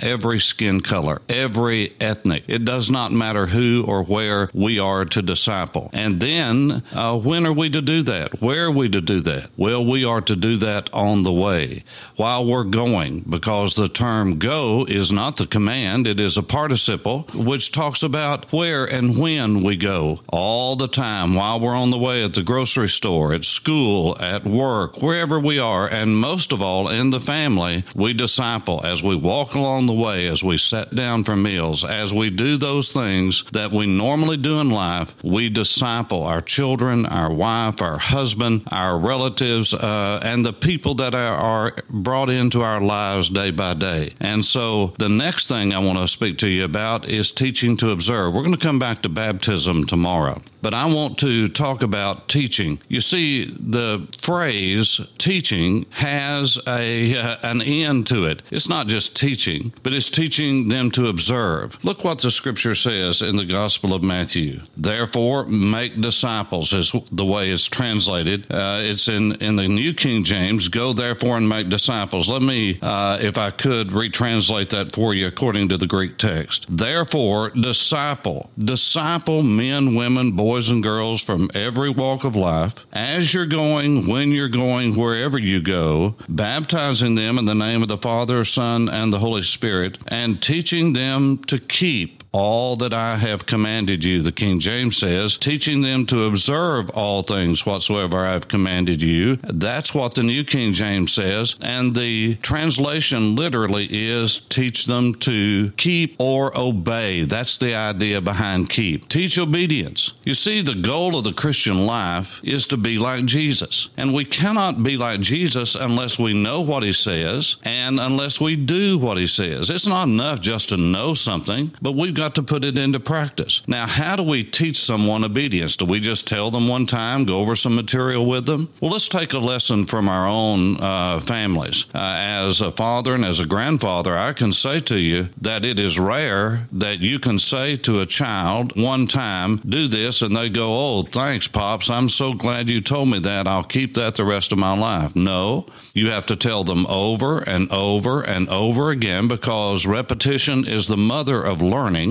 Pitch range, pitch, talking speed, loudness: 100-130 Hz, 115 Hz, 185 wpm, -19 LUFS